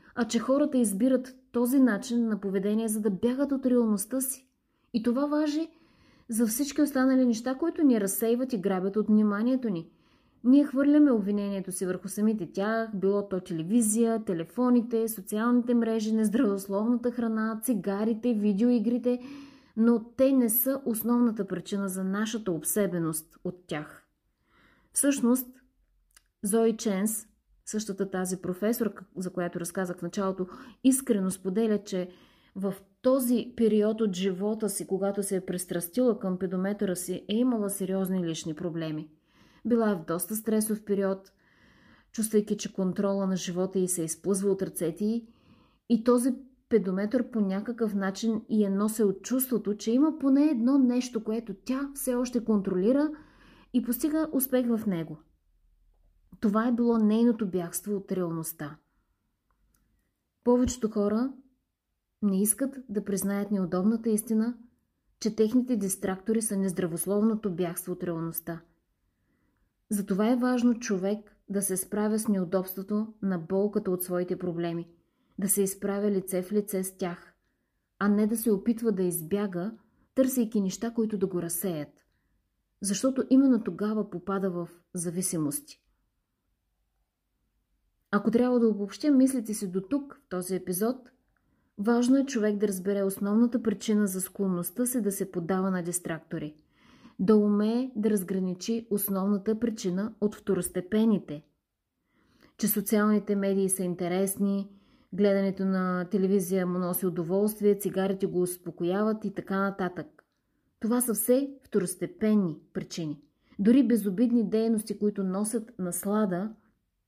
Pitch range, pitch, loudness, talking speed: 190-235 Hz, 210 Hz, -28 LUFS, 130 wpm